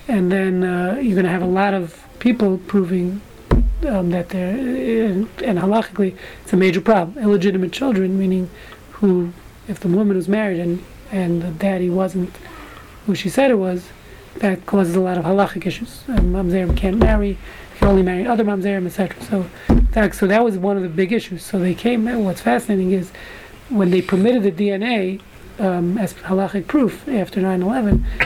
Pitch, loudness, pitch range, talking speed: 195 Hz, -19 LUFS, 185-210 Hz, 185 wpm